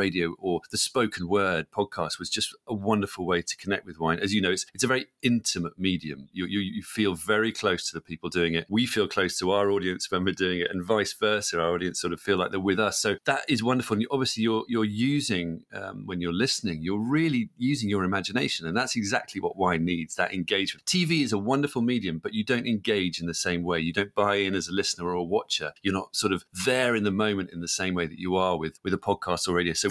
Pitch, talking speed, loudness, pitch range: 95 Hz, 260 wpm, -27 LUFS, 90-110 Hz